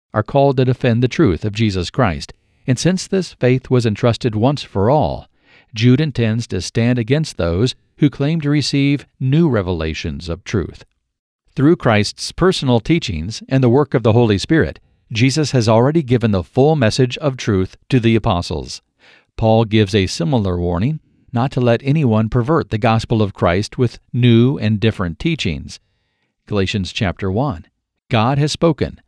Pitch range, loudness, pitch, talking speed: 100-135 Hz, -17 LUFS, 120 Hz, 165 wpm